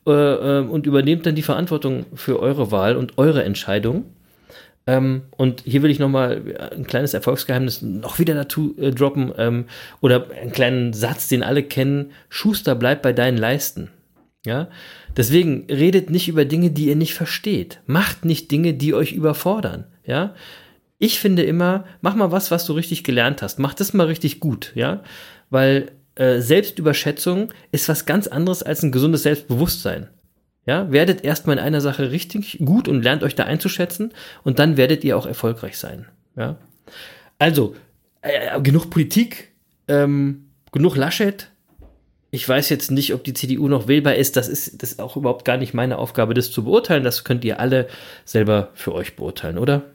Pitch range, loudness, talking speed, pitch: 130-165 Hz, -19 LUFS, 170 wpm, 145 Hz